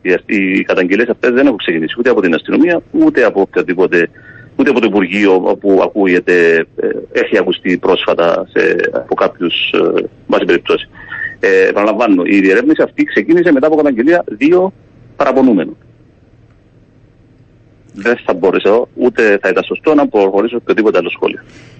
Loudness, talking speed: -12 LUFS, 130 wpm